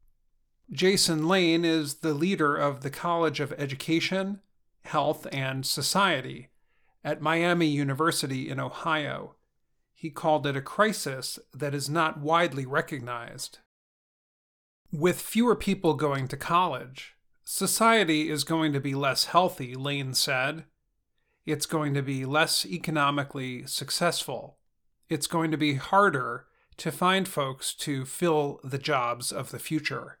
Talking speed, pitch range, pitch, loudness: 130 wpm, 140-170 Hz, 155 Hz, -27 LUFS